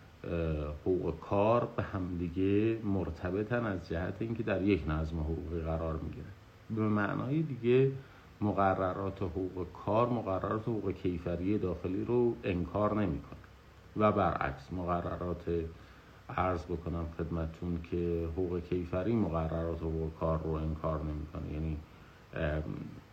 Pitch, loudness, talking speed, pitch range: 90 Hz, -34 LUFS, 115 wpm, 80-100 Hz